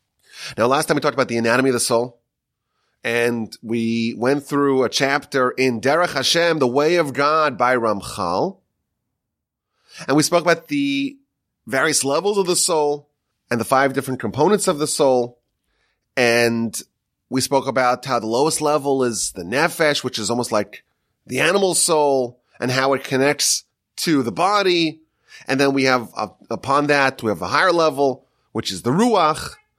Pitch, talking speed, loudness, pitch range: 135 Hz, 170 wpm, -19 LUFS, 120-150 Hz